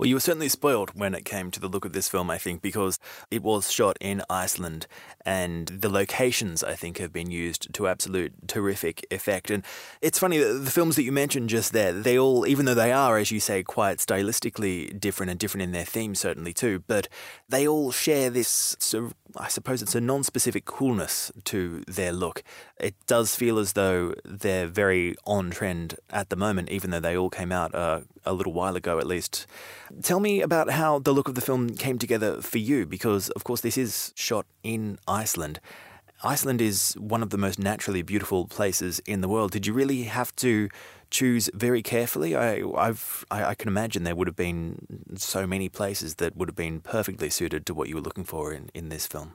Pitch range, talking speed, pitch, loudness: 95-125 Hz, 210 wpm, 105 Hz, -26 LUFS